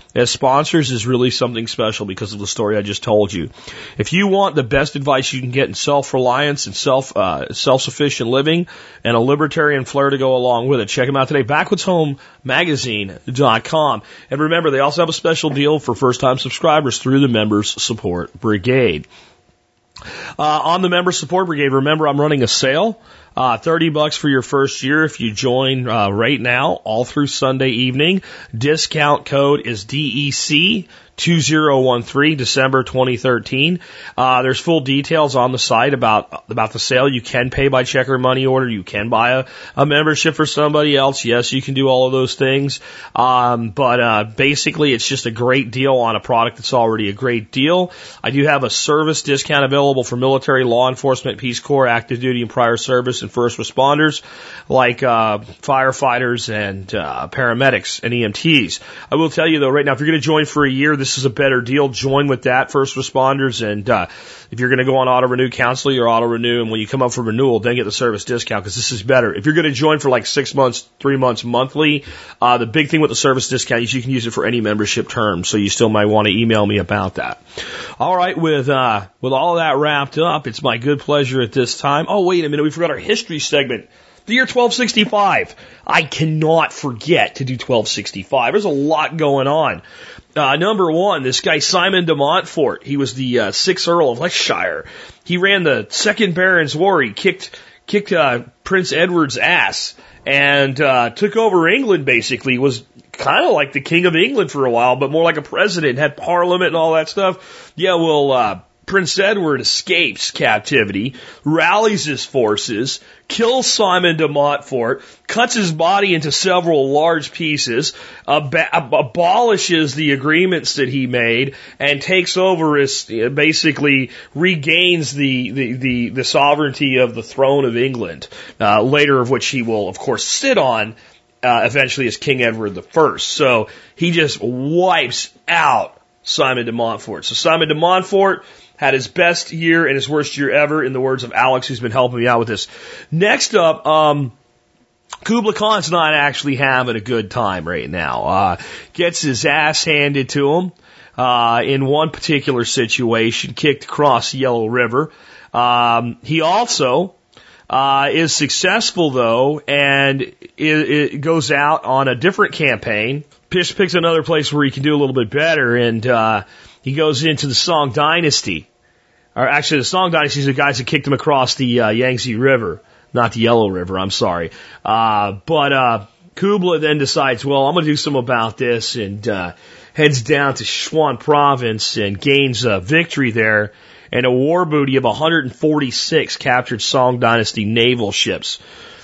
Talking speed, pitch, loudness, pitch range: 190 wpm, 135 Hz, -15 LUFS, 120-155 Hz